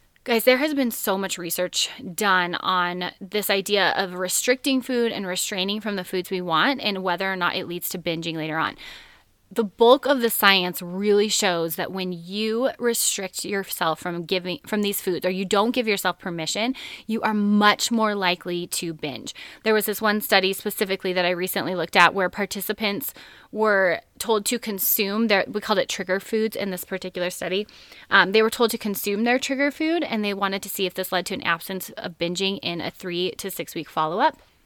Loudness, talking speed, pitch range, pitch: -23 LUFS, 205 wpm, 180-215 Hz, 195 Hz